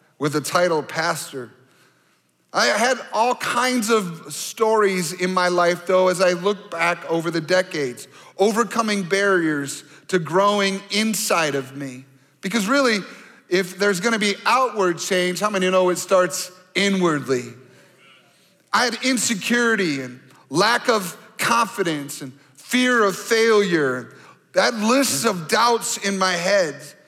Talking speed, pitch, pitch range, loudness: 135 wpm, 185 Hz, 170-220 Hz, -20 LUFS